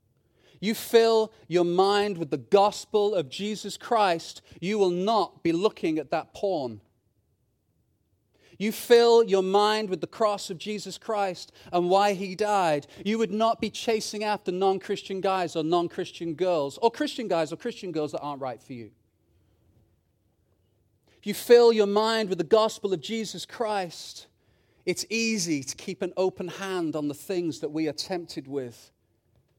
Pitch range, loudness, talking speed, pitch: 145-210 Hz, -26 LUFS, 165 wpm, 185 Hz